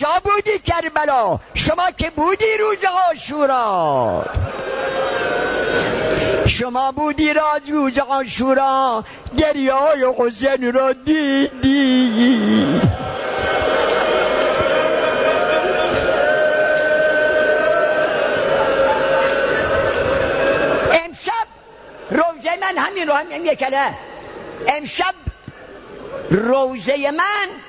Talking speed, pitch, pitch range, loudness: 65 wpm, 305 Hz, 275-375 Hz, -17 LUFS